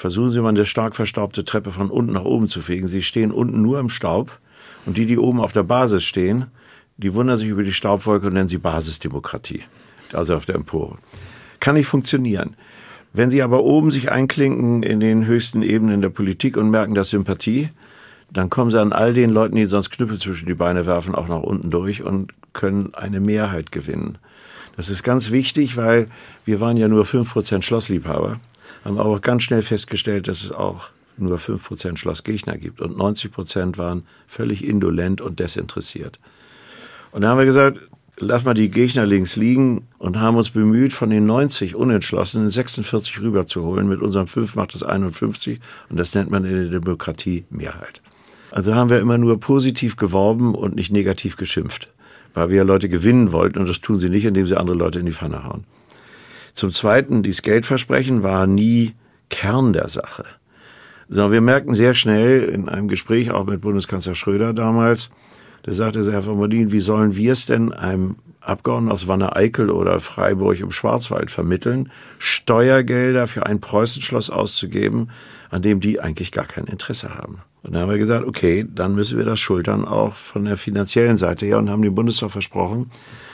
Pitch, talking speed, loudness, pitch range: 105 Hz, 185 wpm, -19 LUFS, 95-120 Hz